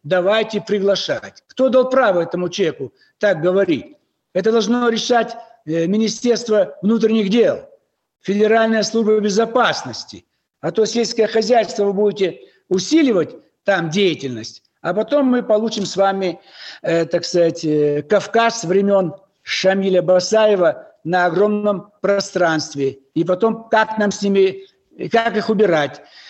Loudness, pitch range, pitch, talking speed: -17 LUFS, 185-225 Hz, 205 Hz, 115 wpm